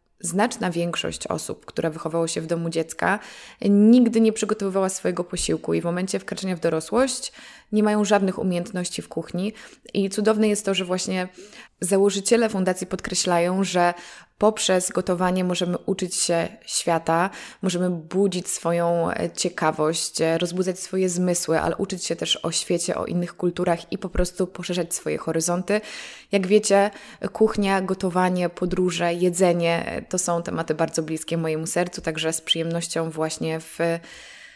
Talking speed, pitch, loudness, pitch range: 140 wpm, 180 Hz, -23 LUFS, 170-195 Hz